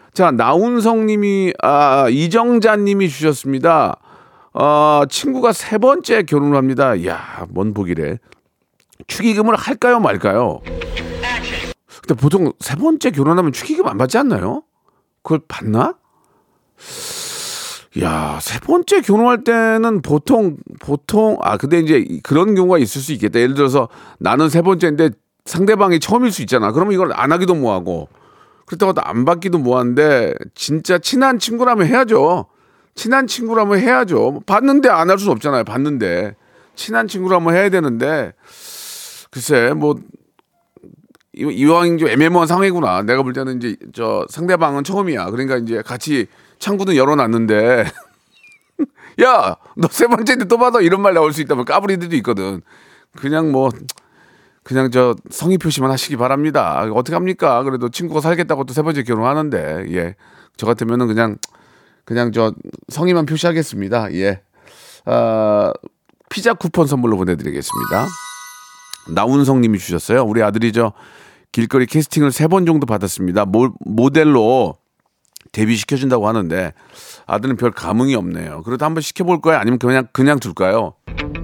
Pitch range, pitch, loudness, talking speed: 125-200 Hz, 155 Hz, -15 LUFS, 310 characters per minute